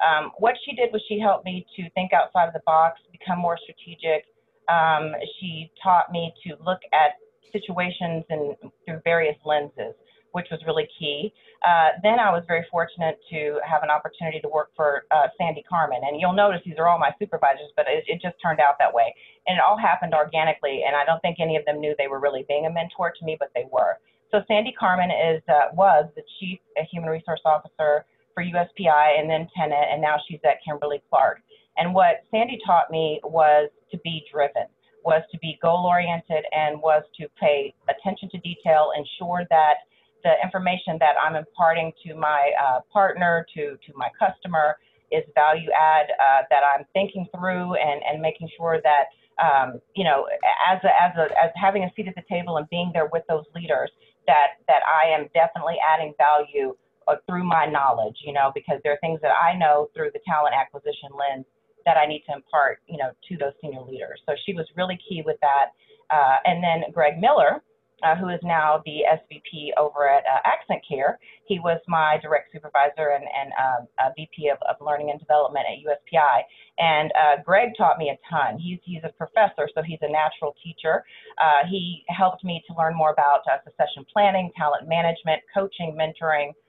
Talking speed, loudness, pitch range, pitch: 200 wpm, -22 LUFS, 150-180 Hz, 160 Hz